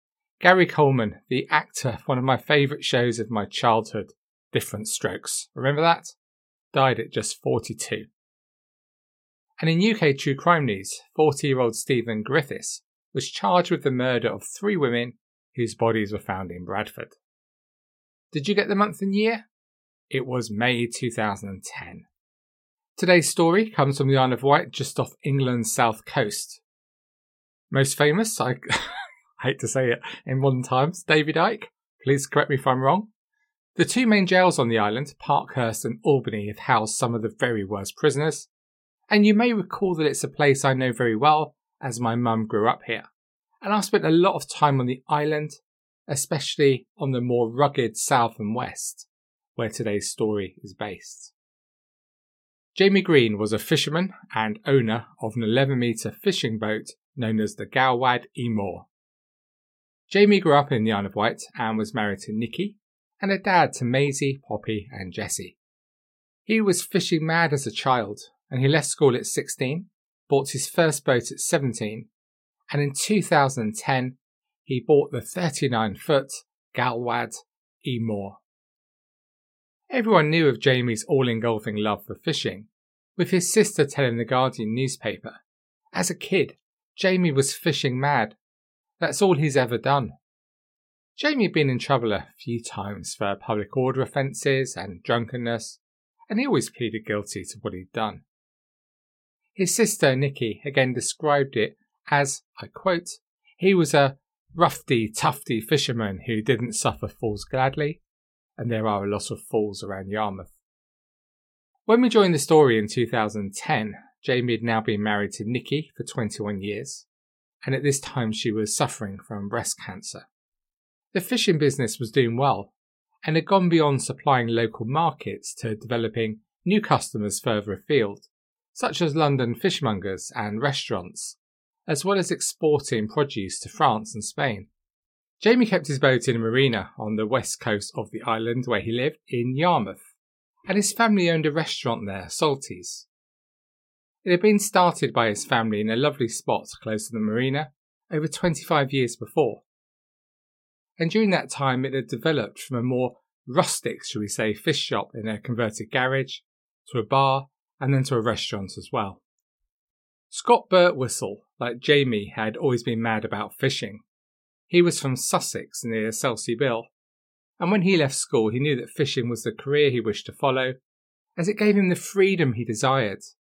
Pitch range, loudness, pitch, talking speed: 110-160 Hz, -24 LUFS, 130 Hz, 165 wpm